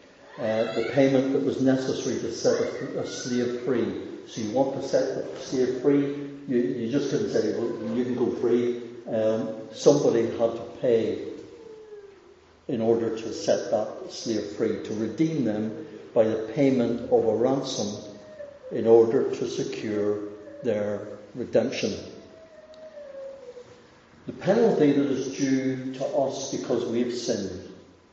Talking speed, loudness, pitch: 140 wpm, -26 LUFS, 130 Hz